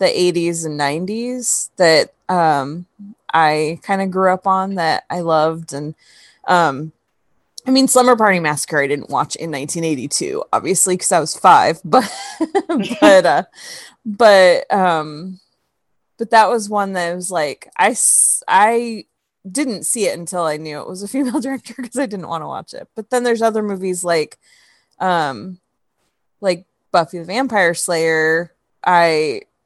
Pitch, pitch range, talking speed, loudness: 185 Hz, 165-235 Hz, 155 wpm, -16 LUFS